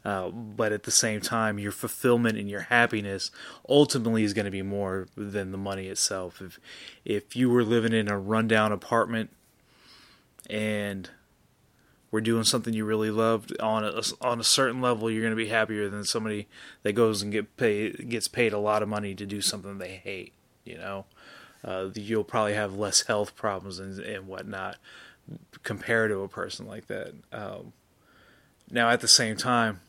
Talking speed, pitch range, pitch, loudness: 180 wpm, 100-115 Hz, 110 Hz, -27 LUFS